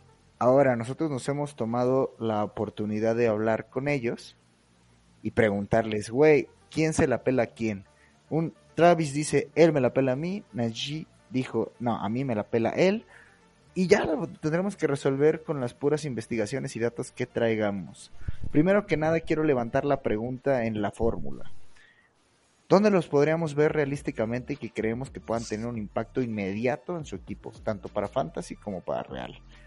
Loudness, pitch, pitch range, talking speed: -27 LUFS, 125 Hz, 110-150 Hz, 170 wpm